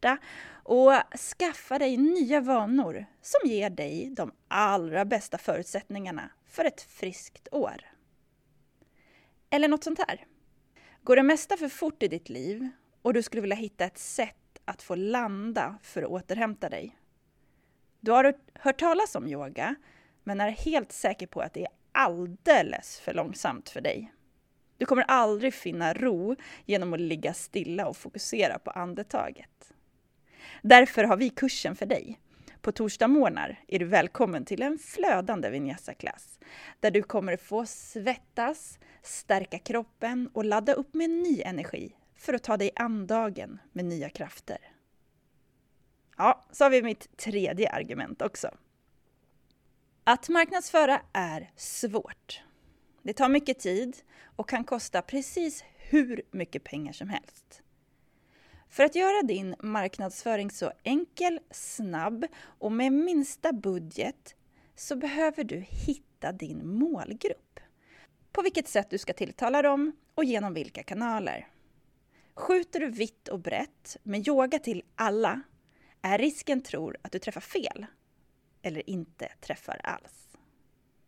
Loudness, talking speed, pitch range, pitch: -28 LUFS, 135 wpm, 205-290 Hz, 240 Hz